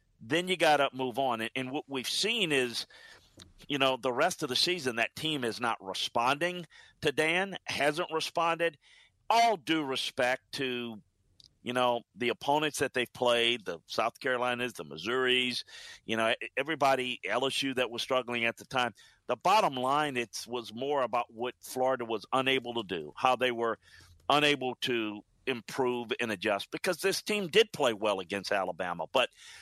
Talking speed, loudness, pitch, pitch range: 170 wpm, -30 LUFS, 130 Hz, 120-150 Hz